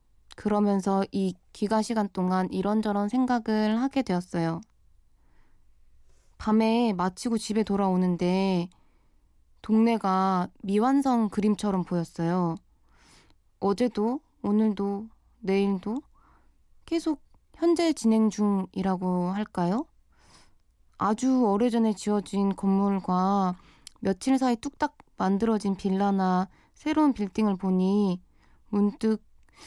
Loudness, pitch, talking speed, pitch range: -27 LUFS, 205 Hz, 215 characters per minute, 185-225 Hz